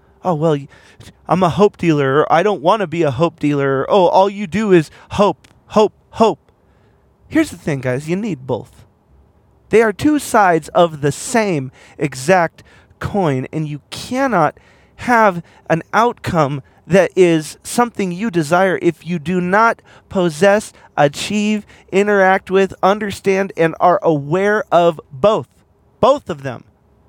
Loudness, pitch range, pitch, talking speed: -16 LUFS, 150-205 Hz, 175 Hz, 145 wpm